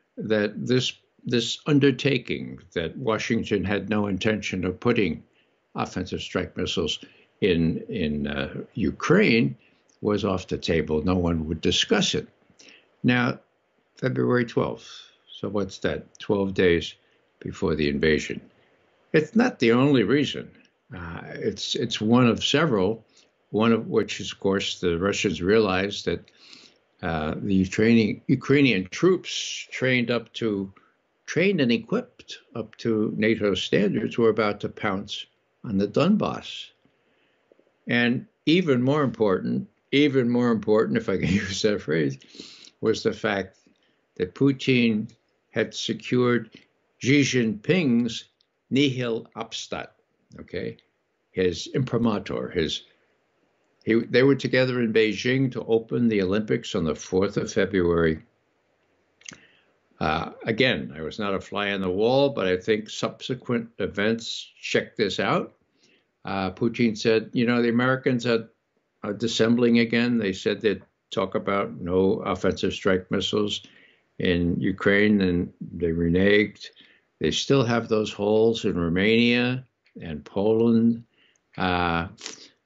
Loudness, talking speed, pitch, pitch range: -24 LUFS, 130 wpm, 110 Hz, 95-120 Hz